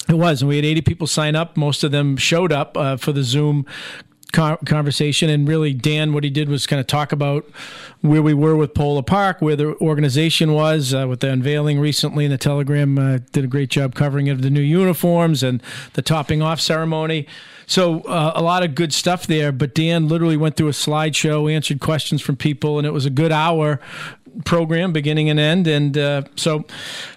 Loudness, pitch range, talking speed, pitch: -18 LUFS, 145-160 Hz, 210 wpm, 150 Hz